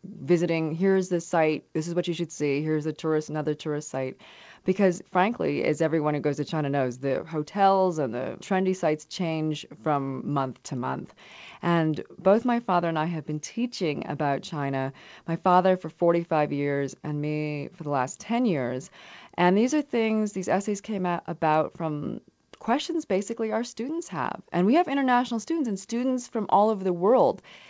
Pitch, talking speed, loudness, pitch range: 170 Hz, 190 wpm, -26 LUFS, 150-200 Hz